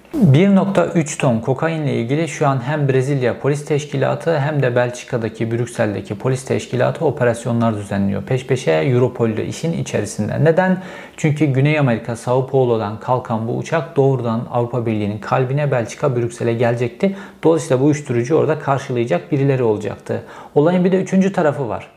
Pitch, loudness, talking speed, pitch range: 130 Hz, -18 LUFS, 145 wpm, 115-155 Hz